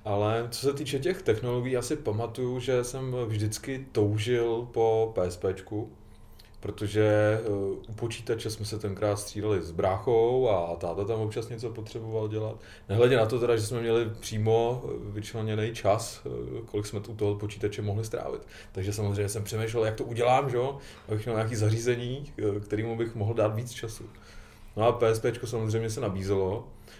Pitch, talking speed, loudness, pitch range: 110 Hz, 160 wpm, -29 LUFS, 105-115 Hz